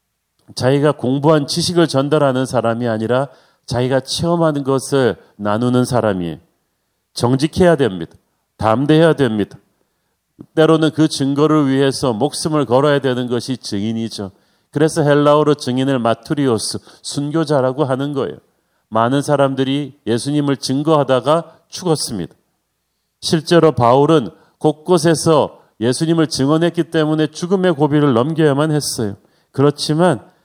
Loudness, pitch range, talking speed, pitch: -16 LUFS, 125-155 Hz, 305 characters per minute, 140 Hz